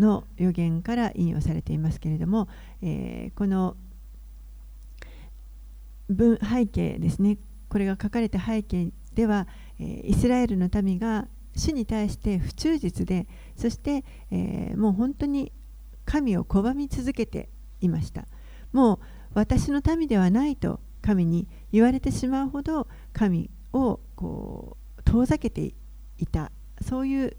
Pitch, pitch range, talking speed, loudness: 210 Hz, 175-240 Hz, 245 characters per minute, -26 LUFS